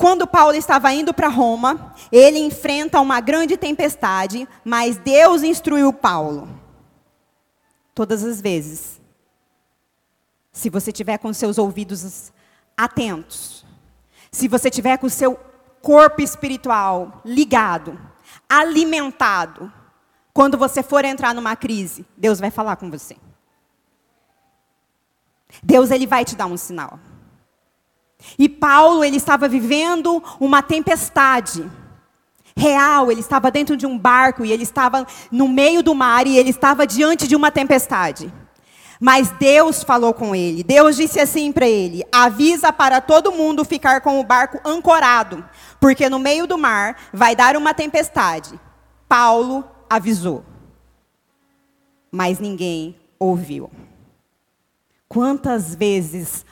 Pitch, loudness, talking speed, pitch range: 260 Hz, -15 LUFS, 125 wpm, 220-290 Hz